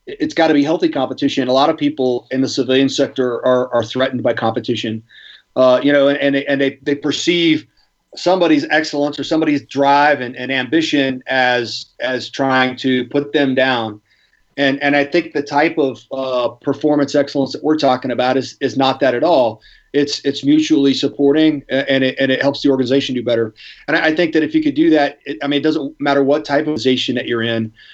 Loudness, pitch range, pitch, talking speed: -16 LUFS, 130-145 Hz, 140 Hz, 215 wpm